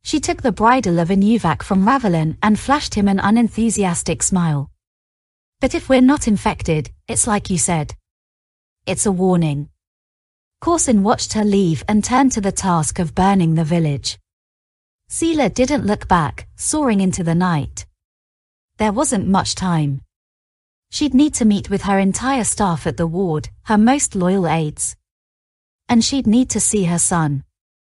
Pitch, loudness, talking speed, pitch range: 185 Hz, -17 LUFS, 155 wpm, 135-215 Hz